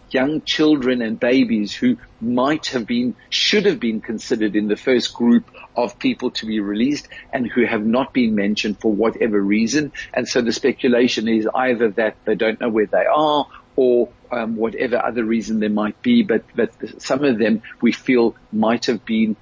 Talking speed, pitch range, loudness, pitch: 190 wpm, 110-130 Hz, -19 LUFS, 120 Hz